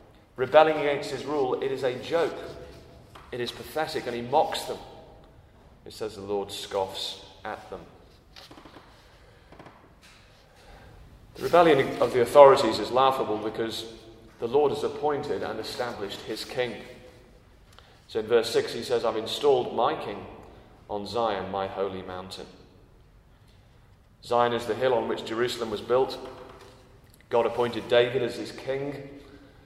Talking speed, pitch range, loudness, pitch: 140 wpm, 105-140 Hz, -26 LUFS, 120 Hz